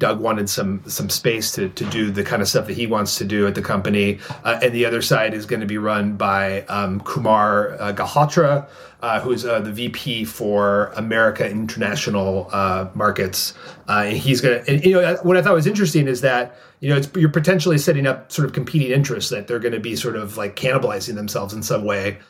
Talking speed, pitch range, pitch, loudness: 220 wpm, 105-140 Hz, 115 Hz, -19 LUFS